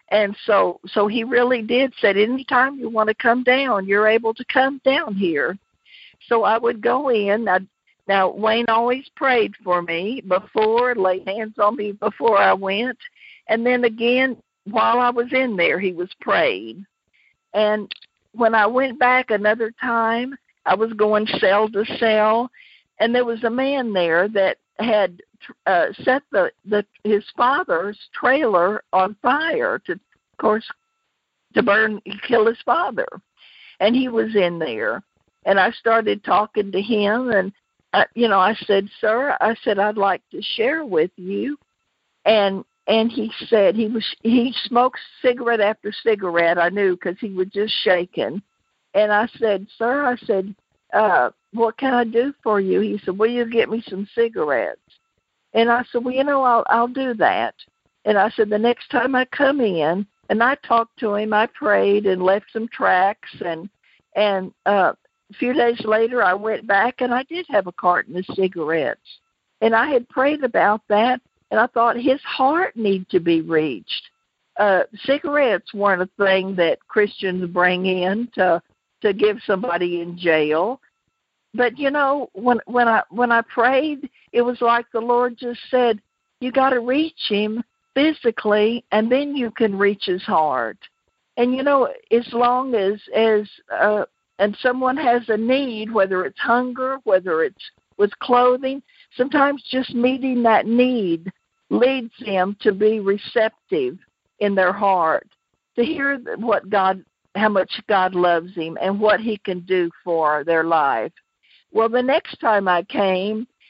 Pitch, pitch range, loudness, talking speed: 225 Hz, 200-250 Hz, -19 LUFS, 165 wpm